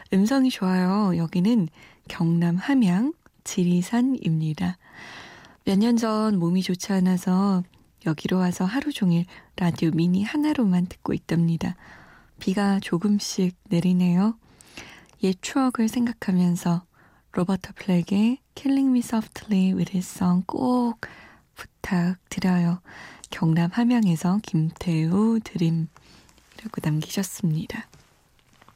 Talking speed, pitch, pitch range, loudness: 270 characters per minute, 185 Hz, 175-220 Hz, -24 LUFS